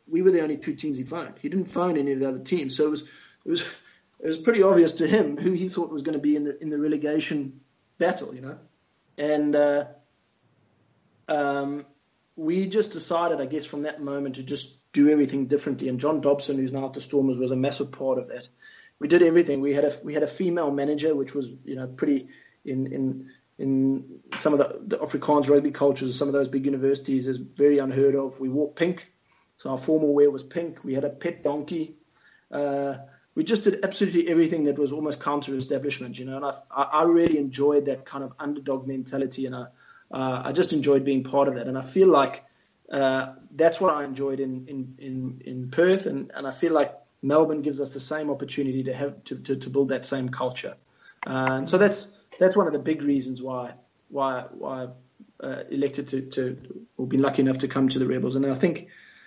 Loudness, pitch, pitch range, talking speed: -25 LUFS, 140 Hz, 135-155 Hz, 220 wpm